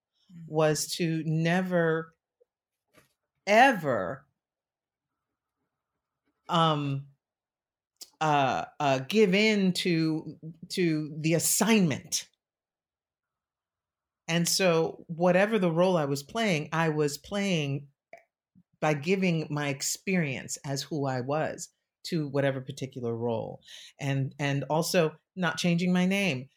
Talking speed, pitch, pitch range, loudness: 95 wpm, 160 Hz, 145-180 Hz, -27 LUFS